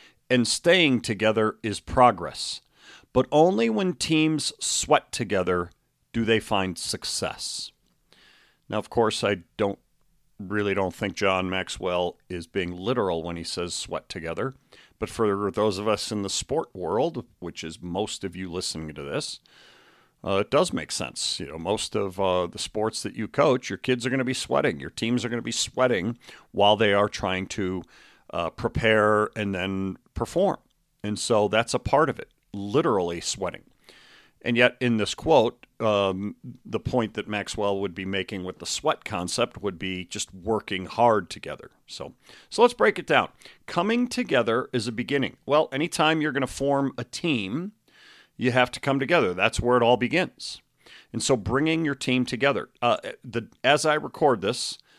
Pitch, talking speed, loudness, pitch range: 110 Hz, 175 wpm, -25 LUFS, 95-130 Hz